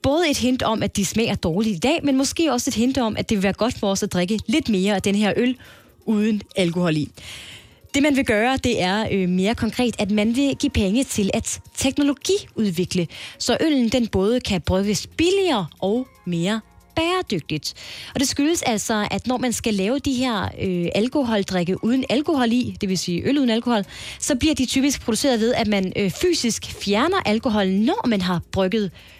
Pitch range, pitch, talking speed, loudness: 200-265 Hz, 225 Hz, 205 wpm, -21 LUFS